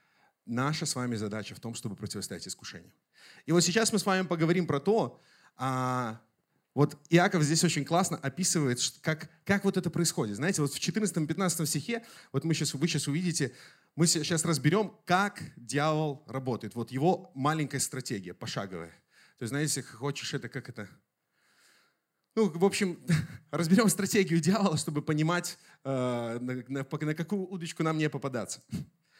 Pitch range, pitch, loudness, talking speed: 130-175 Hz, 155 Hz, -30 LUFS, 150 wpm